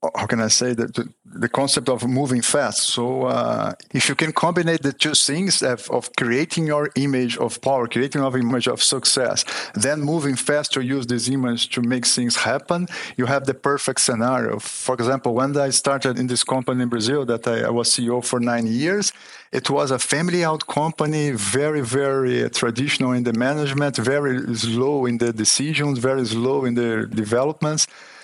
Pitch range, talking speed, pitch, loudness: 120-145 Hz, 185 wpm, 130 Hz, -20 LUFS